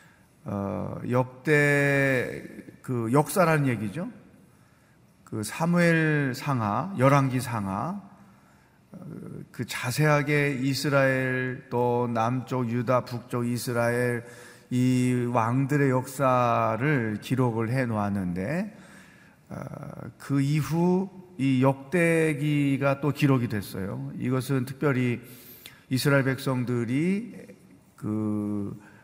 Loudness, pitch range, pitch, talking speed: -26 LUFS, 120-145 Hz, 130 Hz, 180 characters per minute